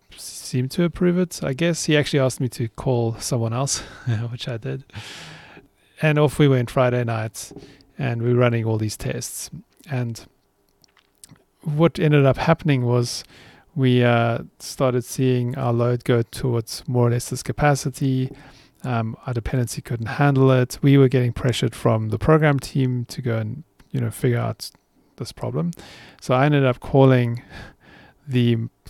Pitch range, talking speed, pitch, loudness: 120-140 Hz, 160 wpm, 130 Hz, -21 LUFS